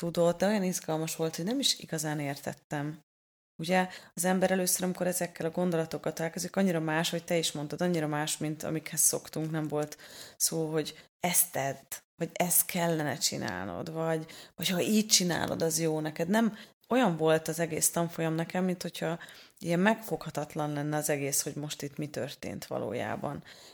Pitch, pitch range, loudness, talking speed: 165 Hz, 155-180 Hz, -30 LUFS, 170 wpm